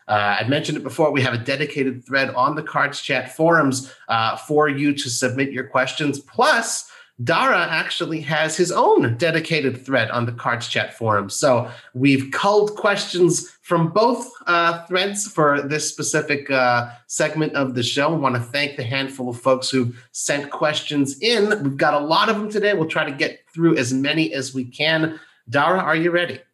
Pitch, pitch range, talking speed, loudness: 145 Hz, 130-160 Hz, 190 wpm, -20 LUFS